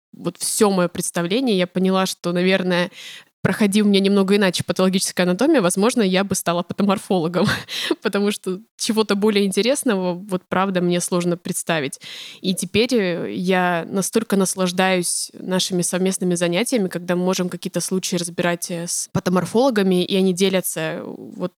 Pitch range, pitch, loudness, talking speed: 180-200 Hz, 185 Hz, -20 LUFS, 135 wpm